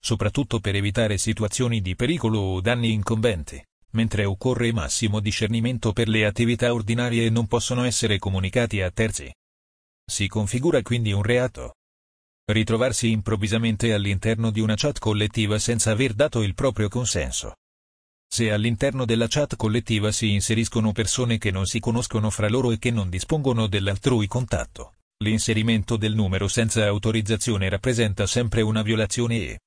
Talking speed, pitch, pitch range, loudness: 145 wpm, 110 Hz, 105-120 Hz, -23 LUFS